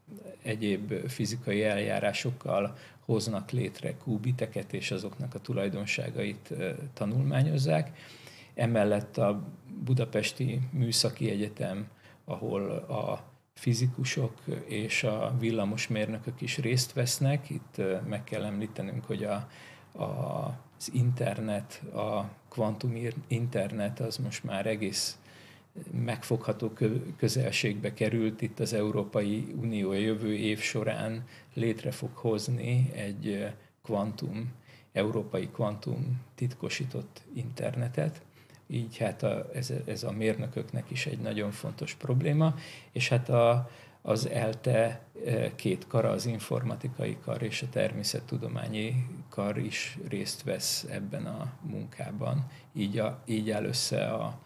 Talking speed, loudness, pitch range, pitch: 110 wpm, -32 LUFS, 110-130 Hz, 120 Hz